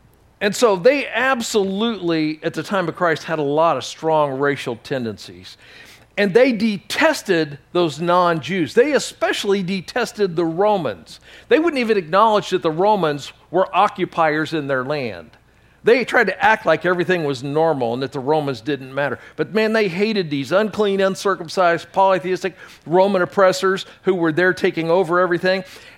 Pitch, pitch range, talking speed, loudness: 180 Hz, 155-200 Hz, 160 wpm, -19 LUFS